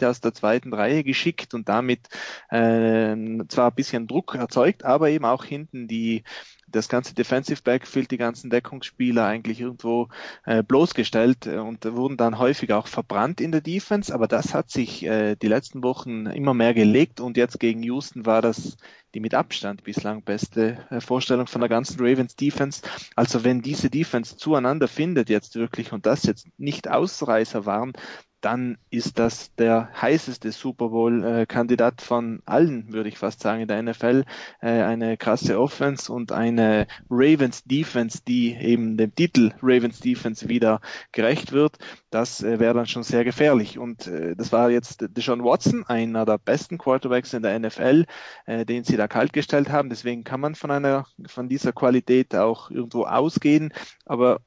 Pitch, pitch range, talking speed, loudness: 120 Hz, 115-130 Hz, 160 wpm, -23 LUFS